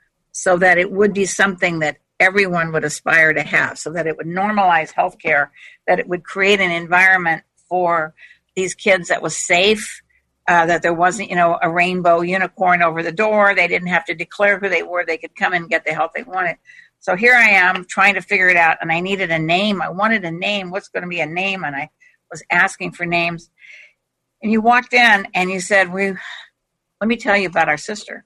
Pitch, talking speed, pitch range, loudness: 180 Hz, 220 wpm, 170-200 Hz, -16 LUFS